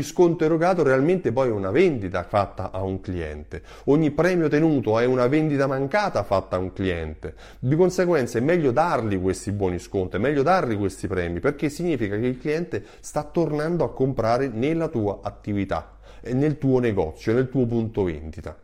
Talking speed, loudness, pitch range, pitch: 175 wpm, -23 LUFS, 95-150 Hz, 120 Hz